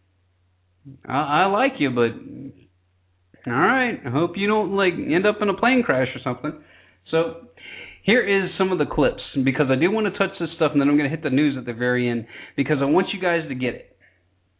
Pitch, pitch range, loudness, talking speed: 140 Hz, 120-185 Hz, -21 LUFS, 220 wpm